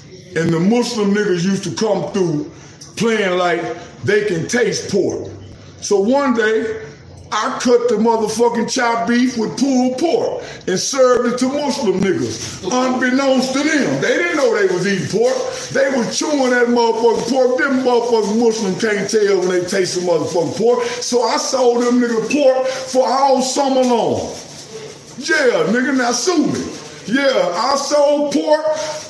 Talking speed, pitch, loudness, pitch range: 160 wpm, 240 Hz, -16 LUFS, 200-270 Hz